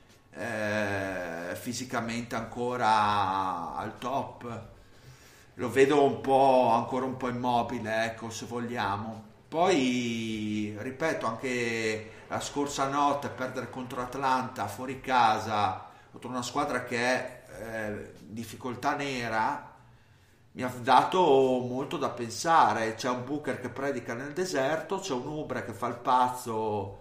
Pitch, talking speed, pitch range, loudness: 125 Hz, 125 wpm, 110-130 Hz, -29 LUFS